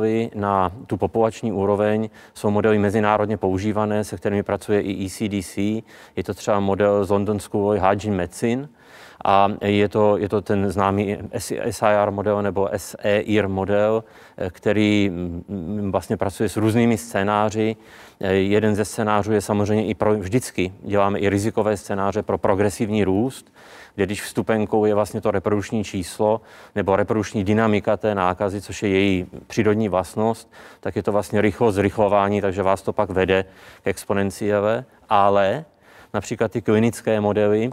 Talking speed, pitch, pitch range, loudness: 145 wpm, 105 Hz, 100-110 Hz, -21 LUFS